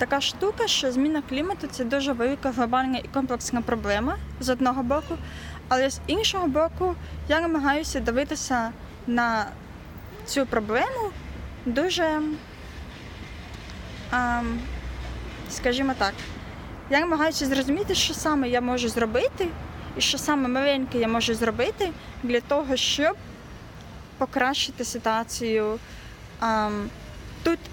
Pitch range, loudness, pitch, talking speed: 240-305 Hz, -25 LUFS, 265 Hz, 105 wpm